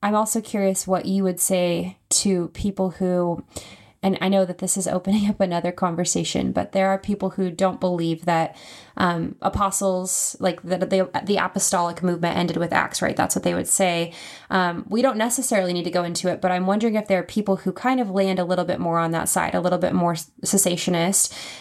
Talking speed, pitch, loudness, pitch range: 215 wpm, 185 Hz, -22 LUFS, 175-195 Hz